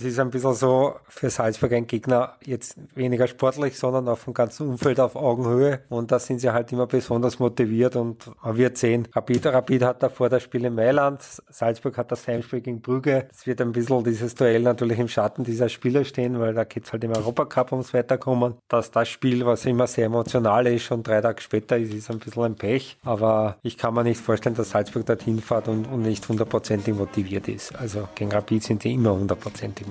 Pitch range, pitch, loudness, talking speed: 115-125 Hz, 120 Hz, -24 LUFS, 215 wpm